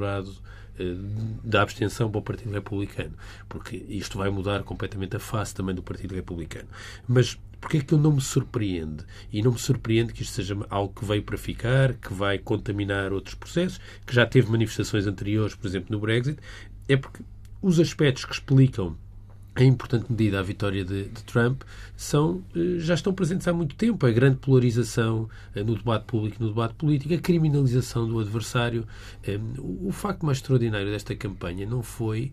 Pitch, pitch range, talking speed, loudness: 110 Hz, 100-125 Hz, 180 wpm, -26 LUFS